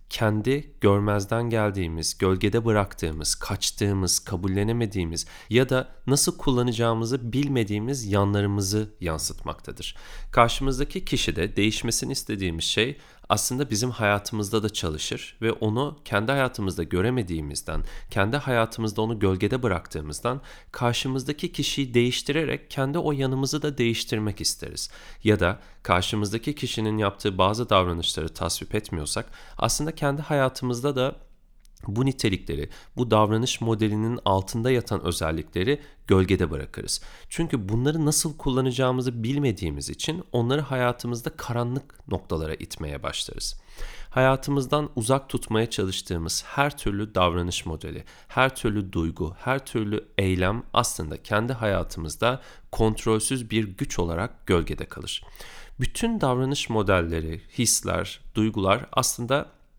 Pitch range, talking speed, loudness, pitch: 95-130 Hz, 110 wpm, -25 LUFS, 110 Hz